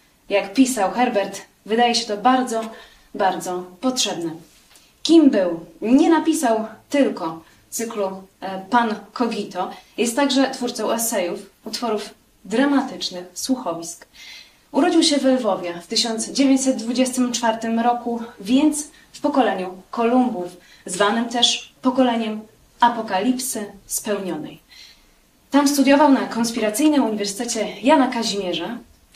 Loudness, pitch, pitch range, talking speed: -20 LUFS, 230 Hz, 195-255 Hz, 95 wpm